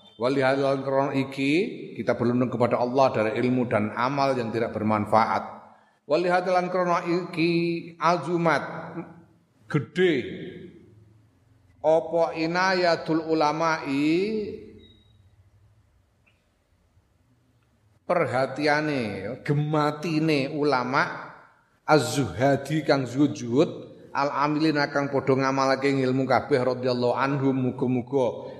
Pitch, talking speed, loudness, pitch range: 135 Hz, 70 wpm, -24 LUFS, 120-160 Hz